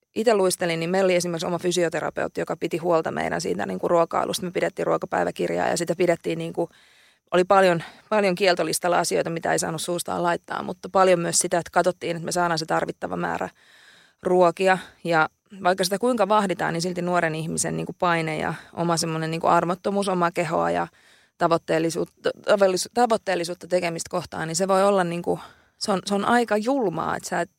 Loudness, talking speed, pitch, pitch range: -23 LUFS, 185 wpm, 175 Hz, 165-190 Hz